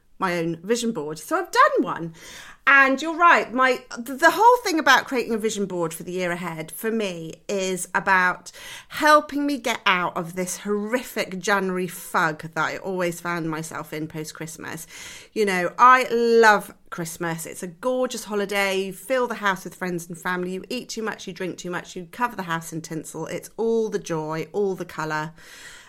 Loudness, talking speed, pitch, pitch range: -22 LUFS, 200 wpm, 190 Hz, 170-235 Hz